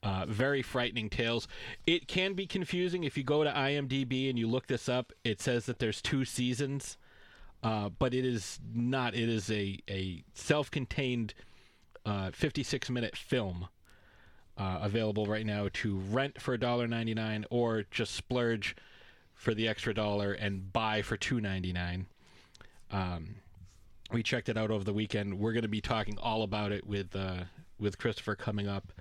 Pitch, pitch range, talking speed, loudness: 110 Hz, 100-125 Hz, 170 wpm, -34 LUFS